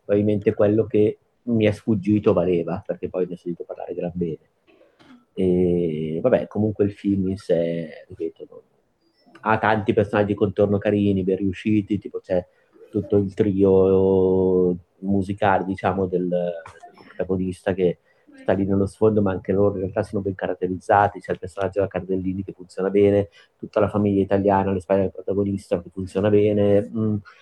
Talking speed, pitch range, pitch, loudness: 165 wpm, 95-105 Hz, 100 Hz, -22 LUFS